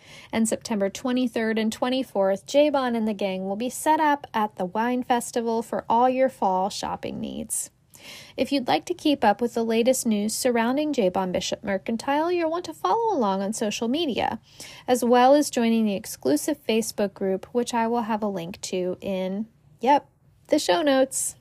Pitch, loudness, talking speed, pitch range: 235 Hz, -24 LUFS, 180 wpm, 205-265 Hz